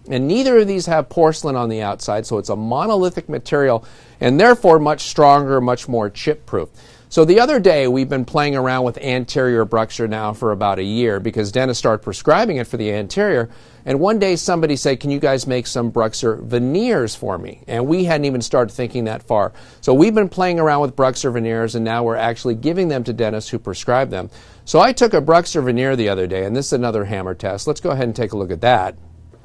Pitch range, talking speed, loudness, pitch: 115-150 Hz, 225 wpm, -17 LUFS, 125 Hz